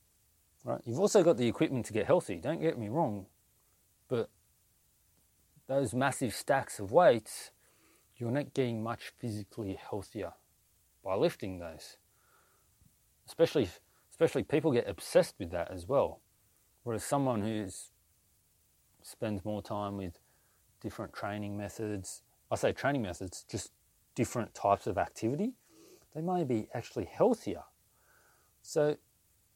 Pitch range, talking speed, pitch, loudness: 100-140 Hz, 120 wpm, 110 Hz, -33 LUFS